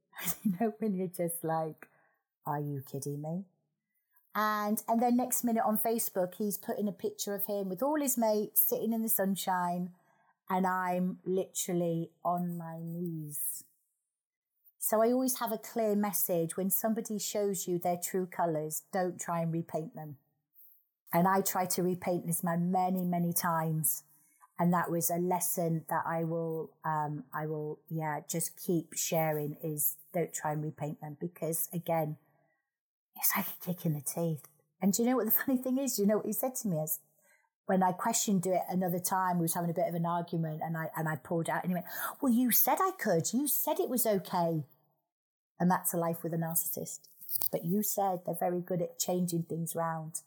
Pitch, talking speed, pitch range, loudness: 175 Hz, 195 wpm, 160-205 Hz, -32 LUFS